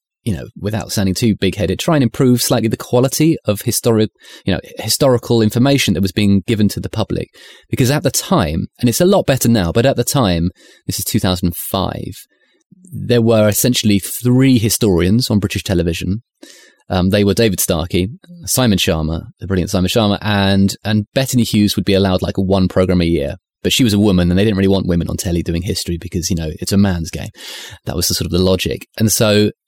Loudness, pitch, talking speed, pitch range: -15 LUFS, 100 Hz, 215 wpm, 90-115 Hz